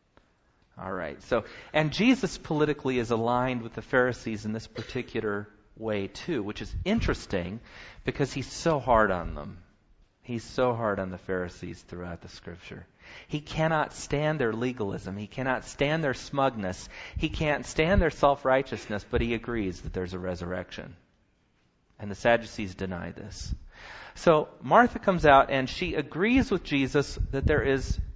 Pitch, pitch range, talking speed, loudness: 115 Hz, 95-135 Hz, 155 wpm, -28 LUFS